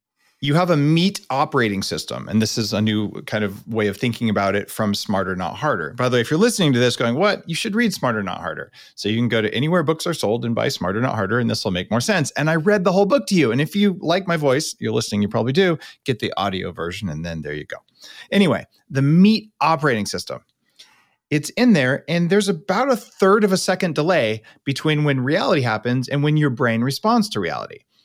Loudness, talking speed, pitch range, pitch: -20 LUFS, 245 wpm, 110-180 Hz, 140 Hz